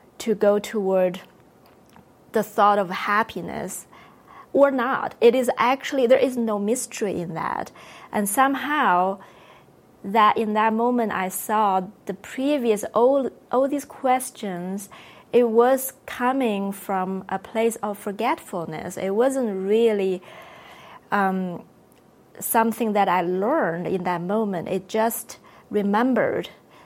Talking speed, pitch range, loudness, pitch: 120 wpm, 195-245 Hz, -23 LUFS, 215 Hz